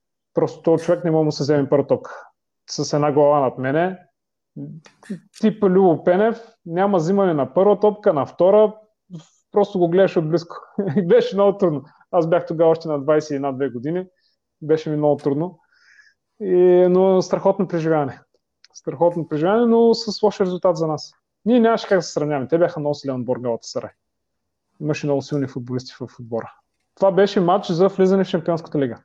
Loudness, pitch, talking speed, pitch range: -19 LUFS, 175 Hz, 170 wpm, 150-195 Hz